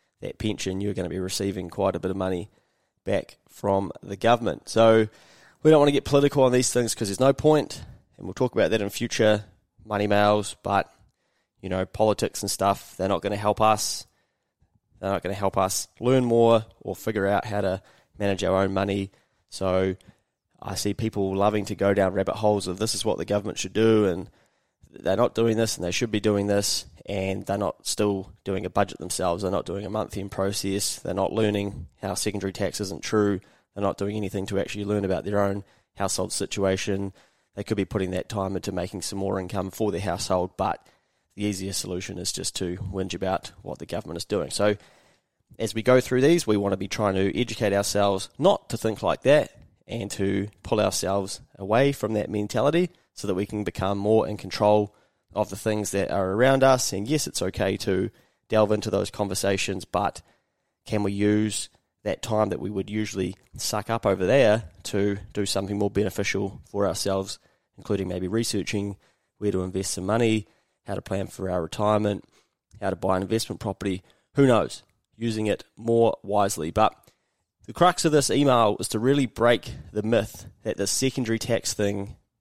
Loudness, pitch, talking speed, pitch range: -25 LUFS, 100 Hz, 200 wpm, 95-110 Hz